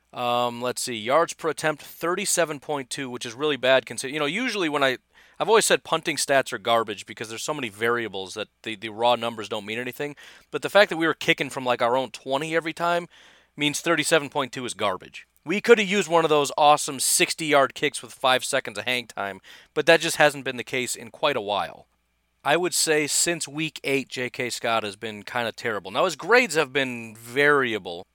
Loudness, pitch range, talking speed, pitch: -23 LUFS, 120-155 Hz, 215 wpm, 135 Hz